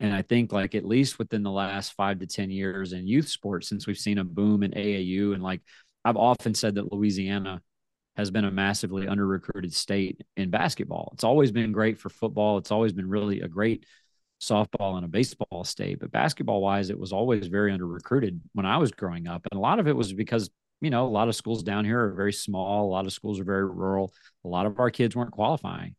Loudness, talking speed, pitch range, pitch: -27 LUFS, 230 wpm, 95-110 Hz, 100 Hz